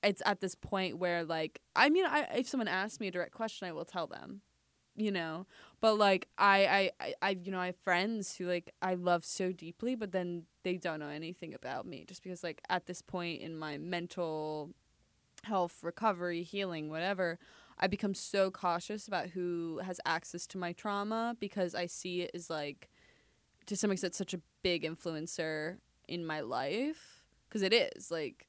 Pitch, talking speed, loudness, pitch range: 180 Hz, 190 wpm, -35 LUFS, 170-200 Hz